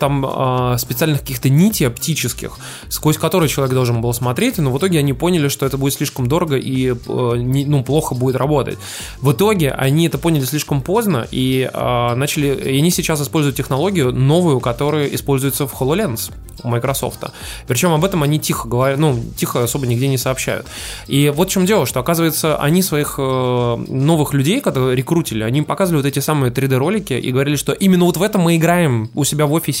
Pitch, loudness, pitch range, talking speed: 140 Hz, -16 LUFS, 130-160 Hz, 195 wpm